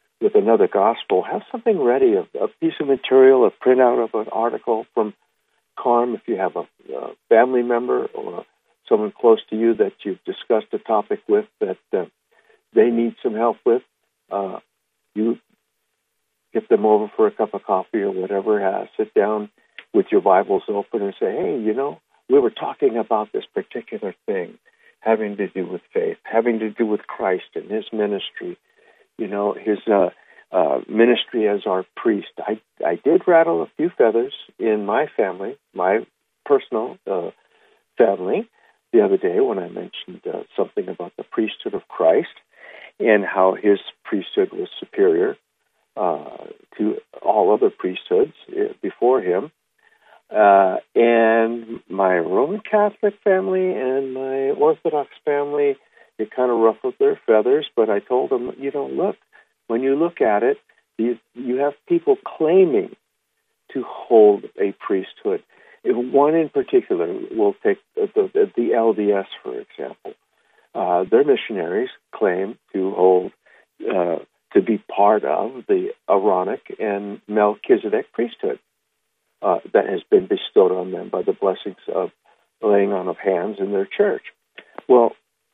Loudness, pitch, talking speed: -20 LUFS, 380 Hz, 155 wpm